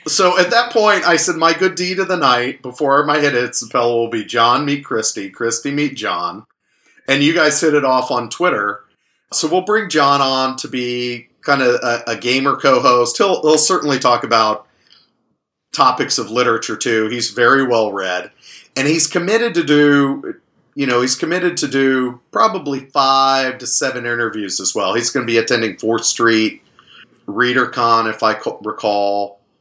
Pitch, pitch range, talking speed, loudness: 130 Hz, 115-150 Hz, 180 wpm, -15 LUFS